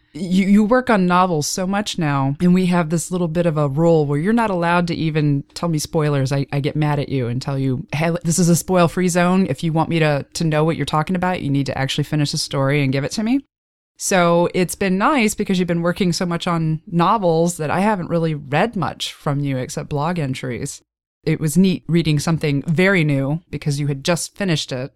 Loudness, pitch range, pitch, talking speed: -19 LUFS, 145-180 Hz, 165 Hz, 245 wpm